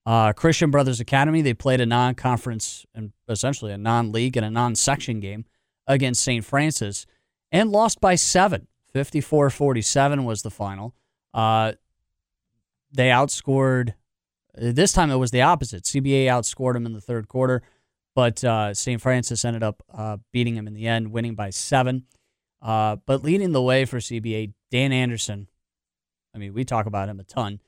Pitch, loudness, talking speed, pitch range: 120 Hz, -22 LUFS, 170 wpm, 110-135 Hz